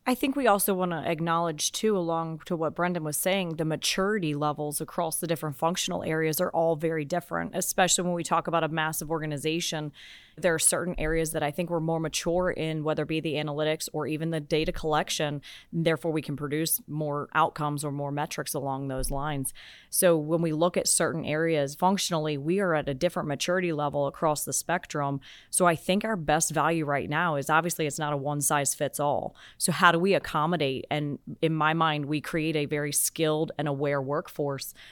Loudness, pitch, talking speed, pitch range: -27 LUFS, 160 Hz, 205 wpm, 150-170 Hz